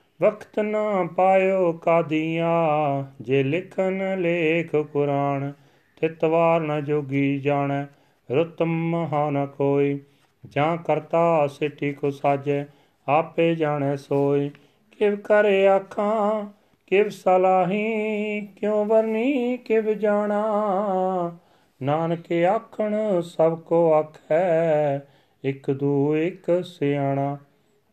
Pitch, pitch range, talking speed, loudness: 165 Hz, 145-190 Hz, 90 wpm, -23 LUFS